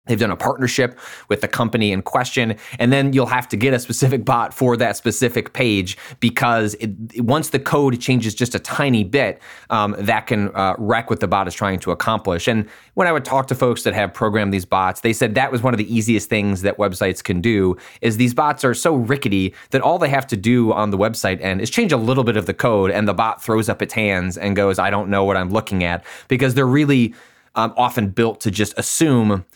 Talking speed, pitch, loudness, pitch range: 240 wpm, 115 Hz, -18 LUFS, 100-125 Hz